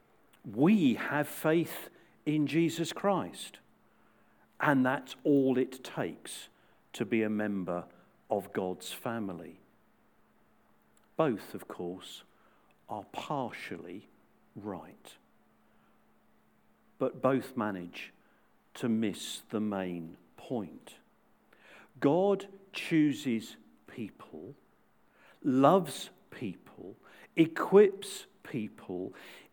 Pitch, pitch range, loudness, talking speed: 130 Hz, 105-165 Hz, -32 LUFS, 80 wpm